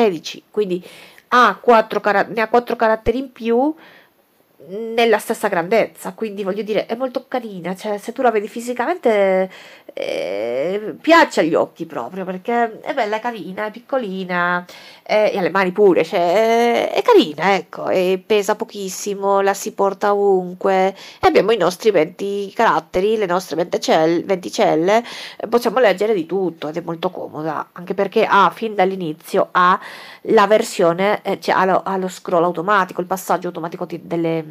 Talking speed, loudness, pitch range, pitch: 165 wpm, -18 LUFS, 185-230 Hz, 200 Hz